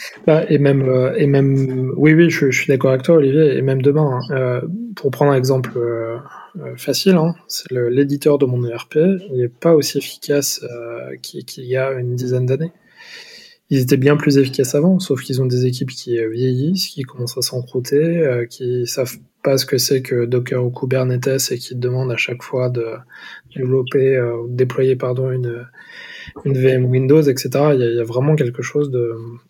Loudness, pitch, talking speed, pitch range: -17 LUFS, 130 Hz, 205 wpm, 125-145 Hz